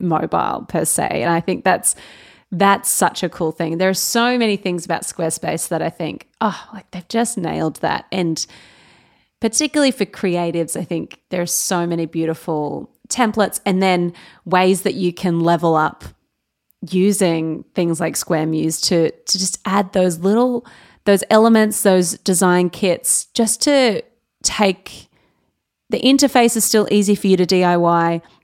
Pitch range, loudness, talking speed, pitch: 170-210 Hz, -17 LUFS, 160 wpm, 185 Hz